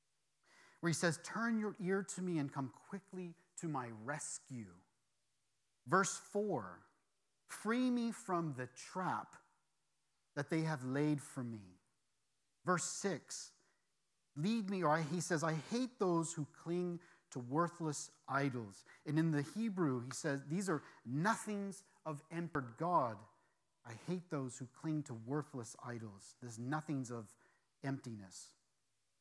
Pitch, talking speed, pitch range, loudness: 150 Hz, 135 wpm, 125-180 Hz, -41 LUFS